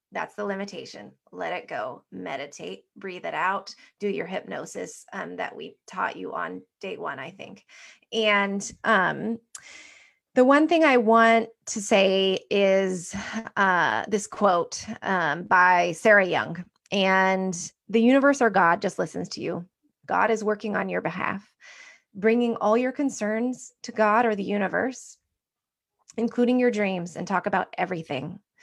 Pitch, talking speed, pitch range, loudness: 210 Hz, 150 wpm, 190-235 Hz, -24 LUFS